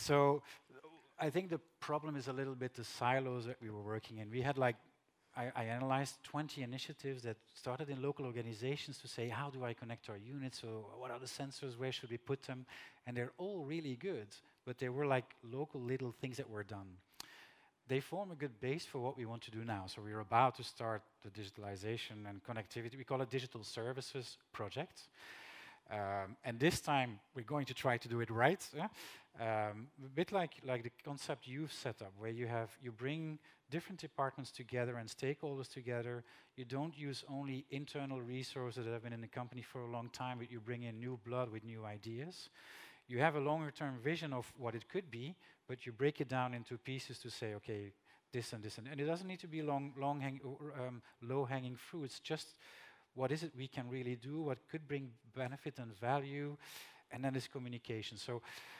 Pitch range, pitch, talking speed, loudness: 120-140 Hz, 130 Hz, 215 wpm, -43 LUFS